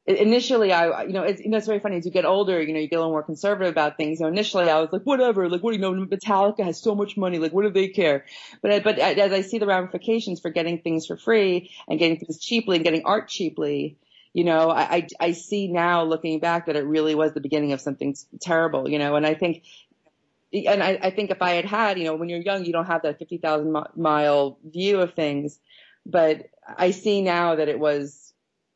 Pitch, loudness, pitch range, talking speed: 170 Hz, -23 LUFS, 155-195 Hz, 255 wpm